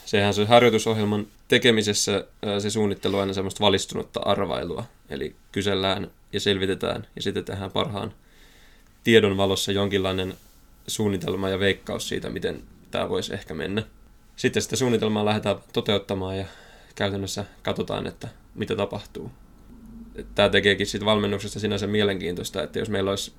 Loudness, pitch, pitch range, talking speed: -24 LUFS, 100 Hz, 95-105 Hz, 135 wpm